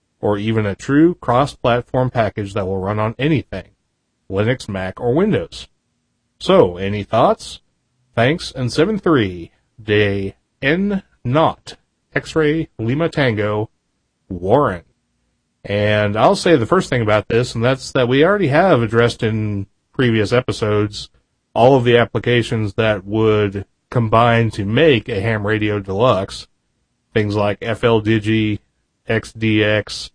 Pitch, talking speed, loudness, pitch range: 110 Hz, 125 wpm, -17 LUFS, 105-125 Hz